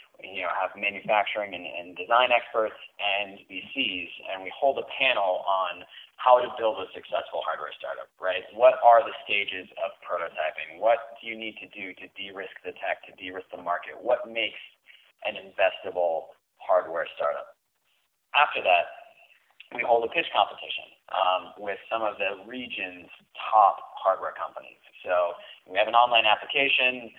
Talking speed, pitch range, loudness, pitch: 165 wpm, 100-140 Hz, -26 LUFS, 115 Hz